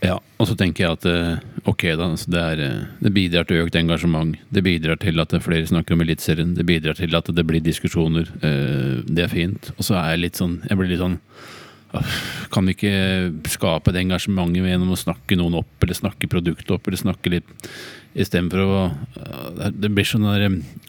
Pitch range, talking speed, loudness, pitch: 85-95 Hz, 195 wpm, -21 LUFS, 90 Hz